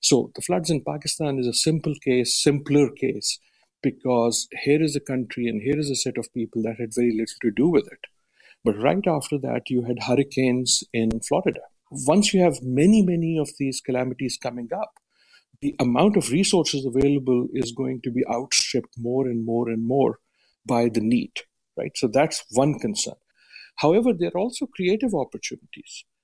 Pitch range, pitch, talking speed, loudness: 125-155 Hz, 135 Hz, 180 wpm, -23 LUFS